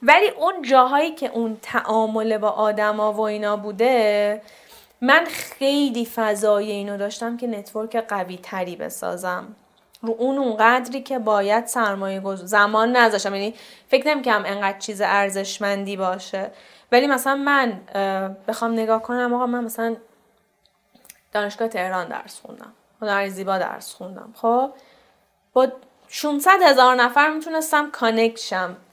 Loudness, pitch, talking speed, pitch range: -21 LUFS, 225 Hz, 130 wpm, 205-250 Hz